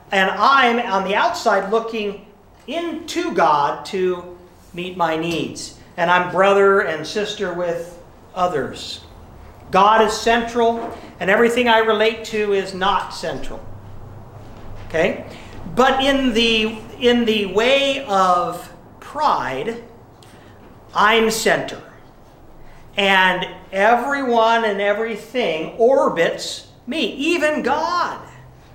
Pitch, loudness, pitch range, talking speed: 205 Hz, -18 LUFS, 180-230 Hz, 100 wpm